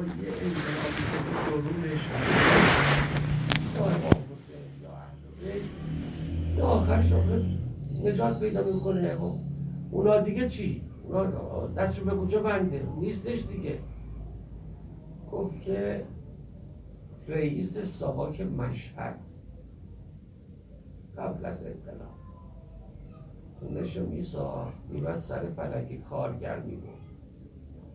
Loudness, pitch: -29 LUFS, 120 Hz